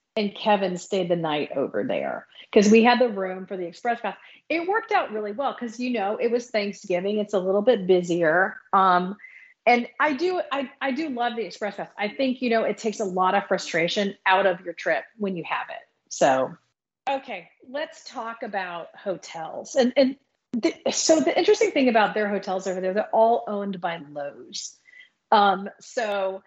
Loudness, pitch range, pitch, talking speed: -24 LUFS, 190-255 Hz, 210 Hz, 195 wpm